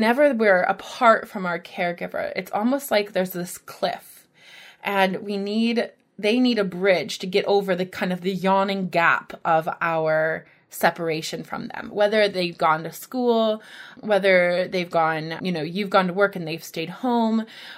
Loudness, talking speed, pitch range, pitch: -22 LUFS, 170 wpm, 175-215 Hz, 195 Hz